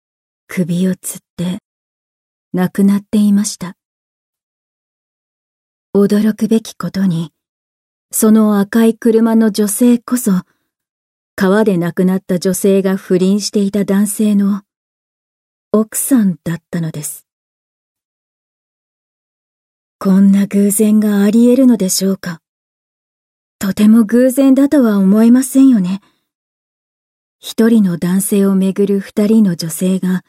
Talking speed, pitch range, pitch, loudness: 210 characters per minute, 185-220 Hz, 200 Hz, -13 LUFS